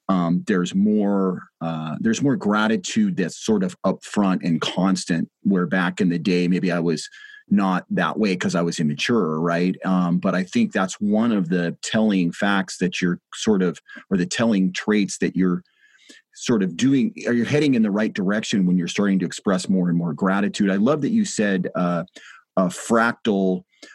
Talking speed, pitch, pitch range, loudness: 190 wpm, 95 Hz, 90-130 Hz, -21 LUFS